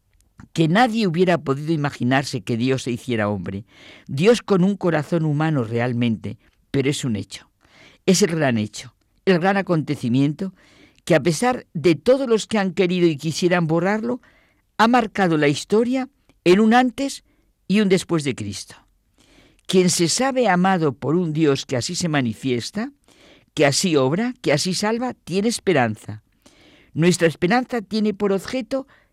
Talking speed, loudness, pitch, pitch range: 155 wpm, -20 LUFS, 170 Hz, 130-200 Hz